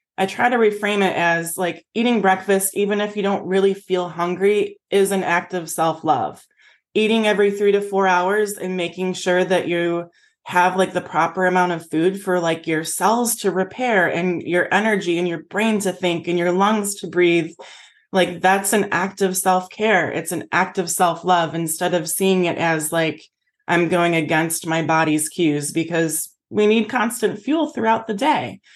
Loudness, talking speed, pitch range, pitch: -19 LUFS, 190 wpm, 170-200 Hz, 185 Hz